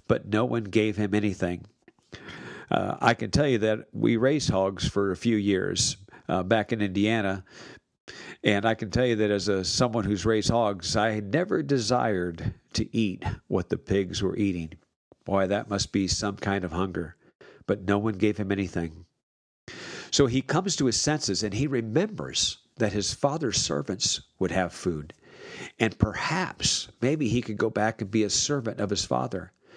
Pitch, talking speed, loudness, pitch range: 105 Hz, 180 wpm, -26 LUFS, 95-115 Hz